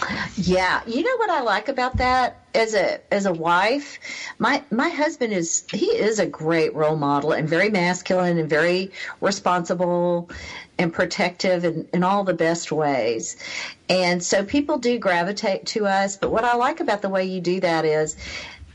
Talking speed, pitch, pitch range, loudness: 175 wpm, 185 Hz, 170-210 Hz, -22 LUFS